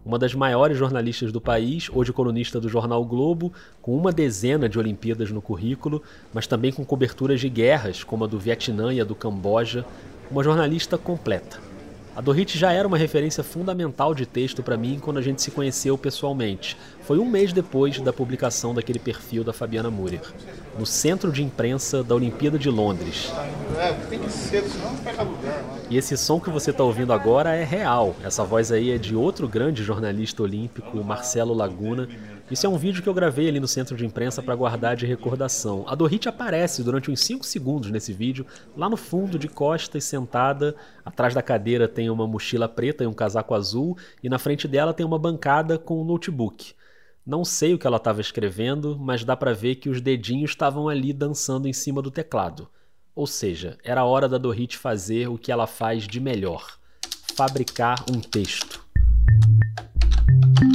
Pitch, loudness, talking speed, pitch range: 125 Hz, -24 LUFS, 180 wpm, 115-145 Hz